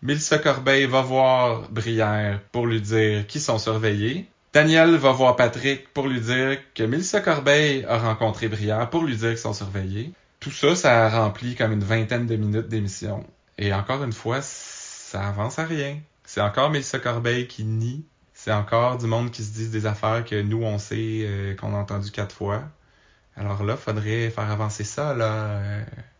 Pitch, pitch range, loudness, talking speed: 115 Hz, 105-130 Hz, -23 LUFS, 190 wpm